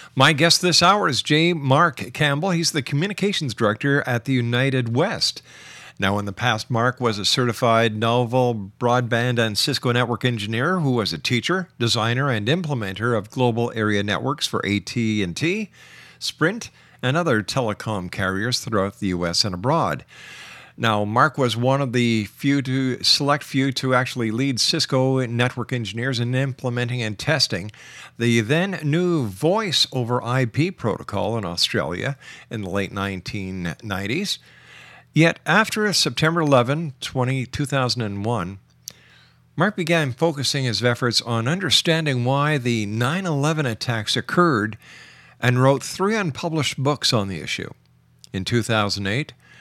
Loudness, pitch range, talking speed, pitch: -21 LUFS, 110-145 Hz, 140 wpm, 125 Hz